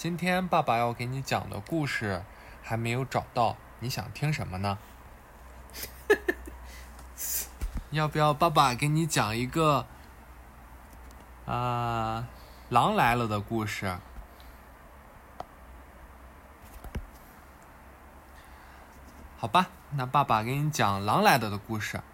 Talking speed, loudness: 145 characters per minute, -28 LUFS